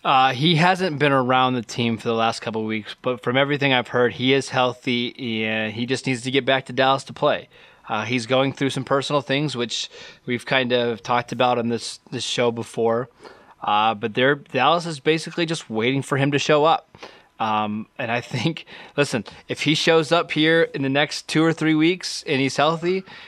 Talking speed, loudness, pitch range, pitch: 210 wpm, -21 LUFS, 120-145 Hz, 130 Hz